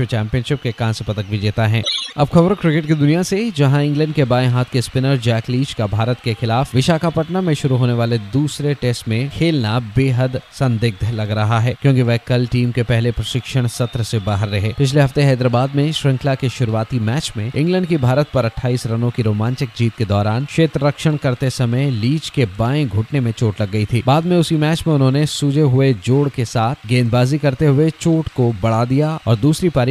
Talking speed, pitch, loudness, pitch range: 210 wpm, 125 Hz, -17 LUFS, 115-145 Hz